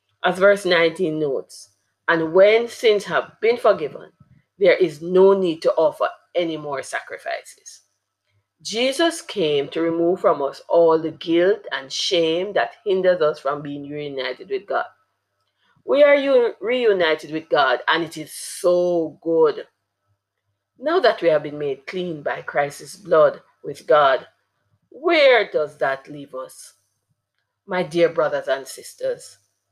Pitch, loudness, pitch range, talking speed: 170 Hz, -20 LUFS, 145-225 Hz, 140 wpm